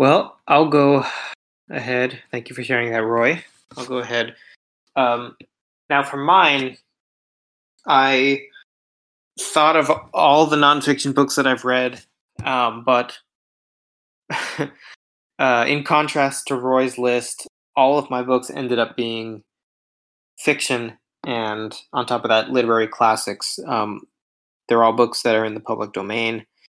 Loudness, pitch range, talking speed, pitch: -19 LUFS, 115-135 Hz, 135 wpm, 125 Hz